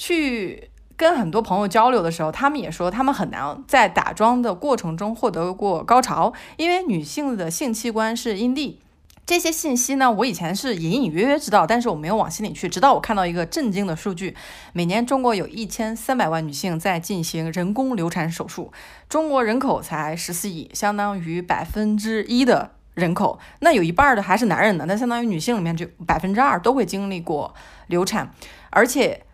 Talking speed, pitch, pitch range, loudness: 305 characters per minute, 215 Hz, 180-245 Hz, -21 LUFS